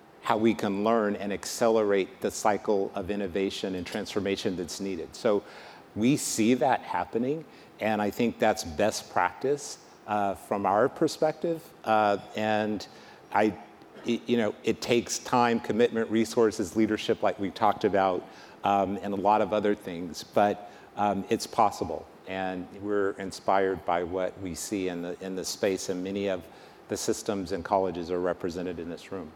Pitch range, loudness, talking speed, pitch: 95-110 Hz, -28 LUFS, 165 wpm, 100 Hz